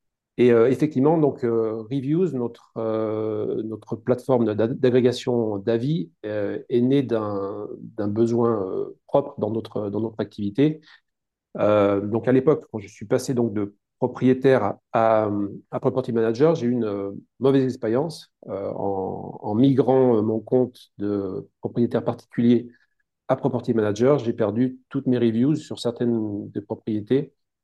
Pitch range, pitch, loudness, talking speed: 110-130 Hz, 115 Hz, -23 LUFS, 130 wpm